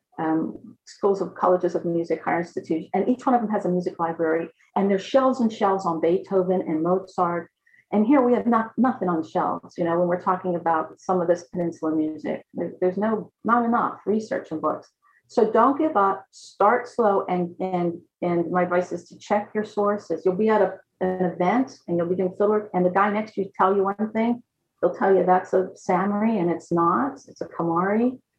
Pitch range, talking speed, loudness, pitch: 175-215 Hz, 215 wpm, -23 LUFS, 185 Hz